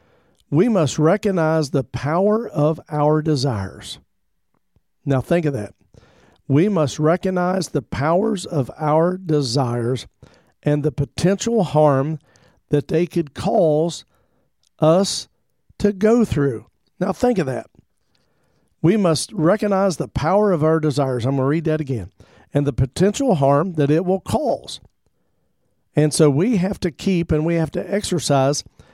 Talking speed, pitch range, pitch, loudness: 145 wpm, 140-180 Hz, 155 Hz, -19 LUFS